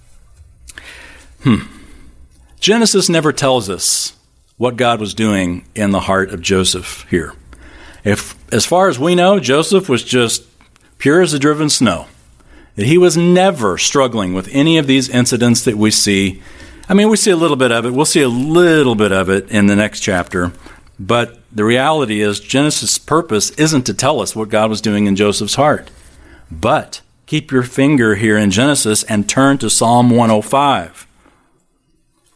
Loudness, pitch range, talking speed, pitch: -13 LUFS, 95-140 Hz, 165 wpm, 115 Hz